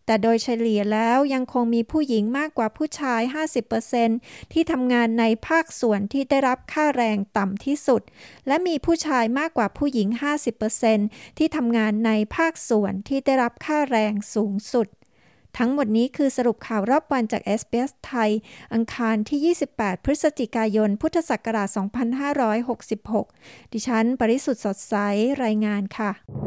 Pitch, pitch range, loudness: 235 Hz, 220-275 Hz, -23 LUFS